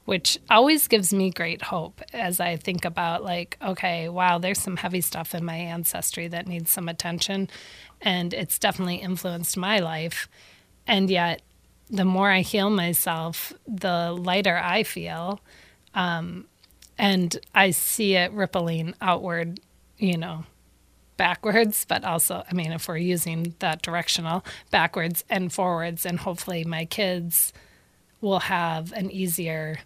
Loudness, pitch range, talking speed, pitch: -24 LUFS, 170-190 Hz, 145 wpm, 175 Hz